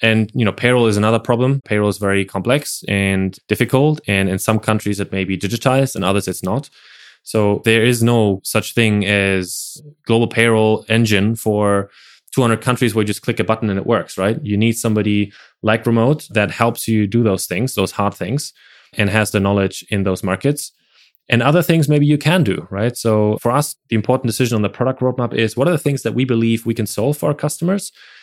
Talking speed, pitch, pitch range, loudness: 215 wpm, 115 Hz, 105-130 Hz, -17 LUFS